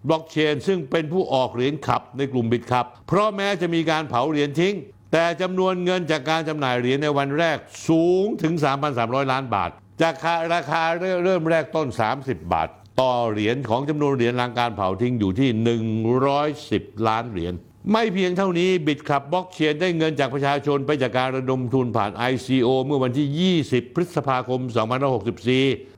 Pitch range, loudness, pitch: 125-165 Hz, -22 LUFS, 140 Hz